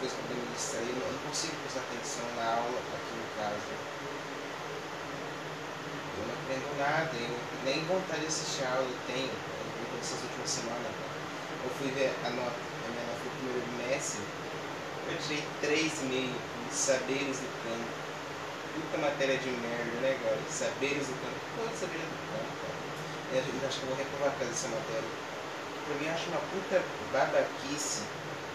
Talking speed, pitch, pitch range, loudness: 170 wpm, 135 Hz, 130-145 Hz, -34 LUFS